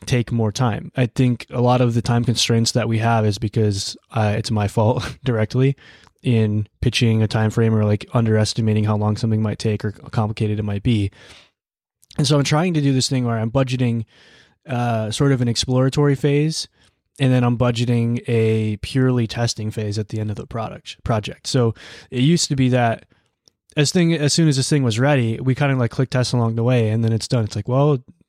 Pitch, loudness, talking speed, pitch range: 120 Hz, -19 LUFS, 220 wpm, 110-130 Hz